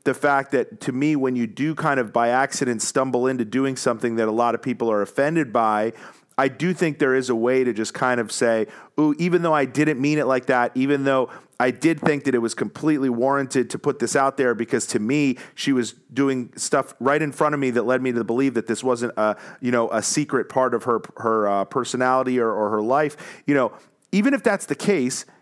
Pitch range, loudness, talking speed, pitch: 120-140 Hz, -22 LUFS, 240 wpm, 130 Hz